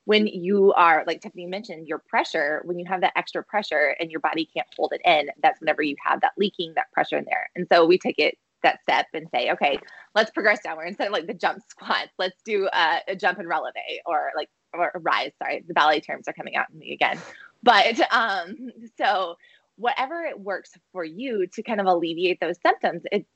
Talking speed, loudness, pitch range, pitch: 225 wpm, -23 LUFS, 170-210 Hz, 185 Hz